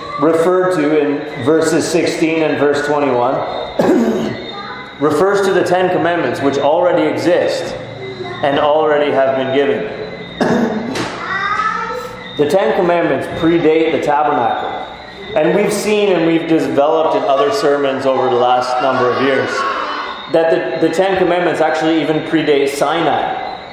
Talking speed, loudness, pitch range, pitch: 130 wpm, -14 LUFS, 145-180 Hz, 160 Hz